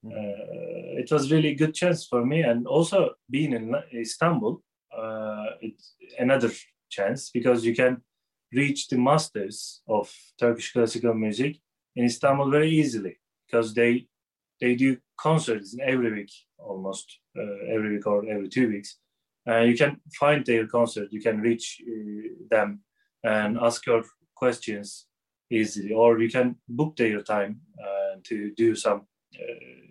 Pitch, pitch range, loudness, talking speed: 120 Hz, 110-145 Hz, -25 LUFS, 150 wpm